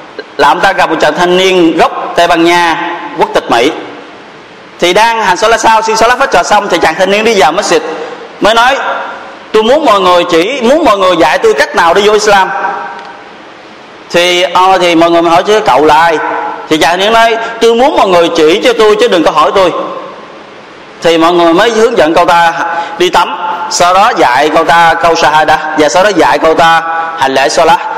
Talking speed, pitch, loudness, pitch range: 225 wpm, 175 Hz, -7 LUFS, 165-220 Hz